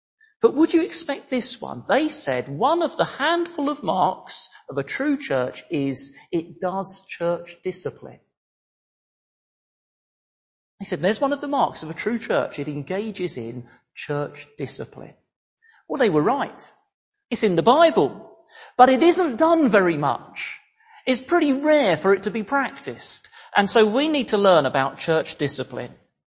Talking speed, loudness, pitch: 160 wpm, -22 LUFS, 220 Hz